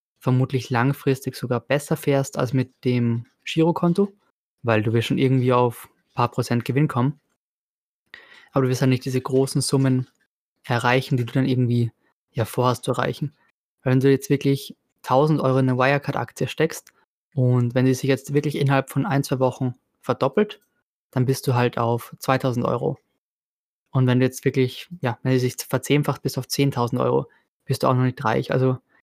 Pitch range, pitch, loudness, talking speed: 125-140 Hz, 130 Hz, -22 LUFS, 180 wpm